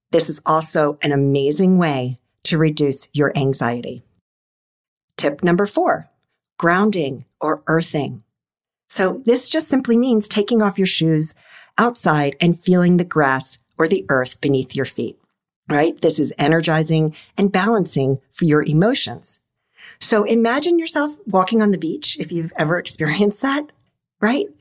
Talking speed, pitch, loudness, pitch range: 140 wpm, 165 Hz, -18 LUFS, 150-205 Hz